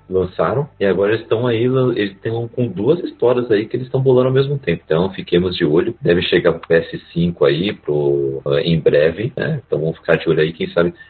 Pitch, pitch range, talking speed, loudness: 95 Hz, 85-125 Hz, 220 wpm, -17 LUFS